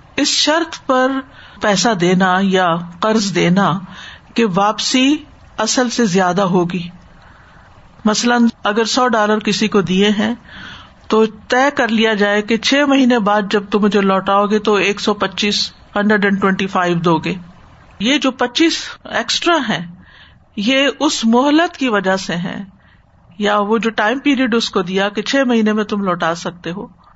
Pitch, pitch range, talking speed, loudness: 215 Hz, 195-245 Hz, 160 wpm, -15 LUFS